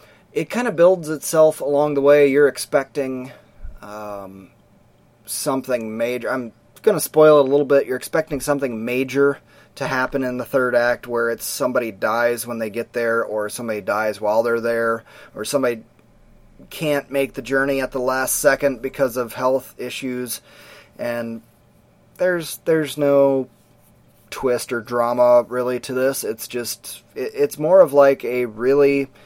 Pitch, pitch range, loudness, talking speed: 130 Hz, 115-140 Hz, -19 LUFS, 160 wpm